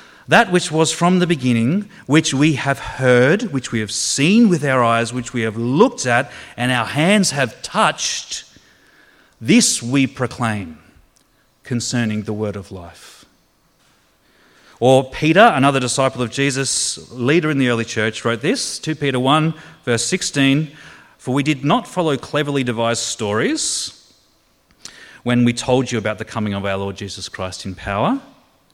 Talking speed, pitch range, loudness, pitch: 155 wpm, 115-150 Hz, -17 LUFS, 125 Hz